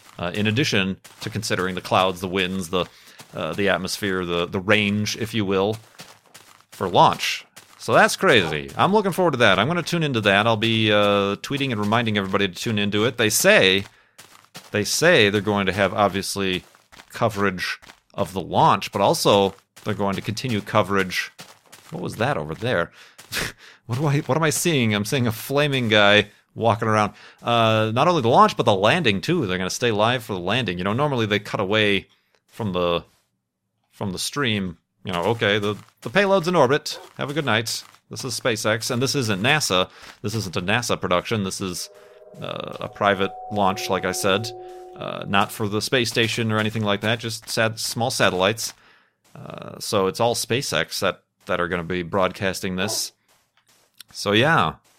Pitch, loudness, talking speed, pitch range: 105 Hz, -21 LUFS, 190 wpm, 95-115 Hz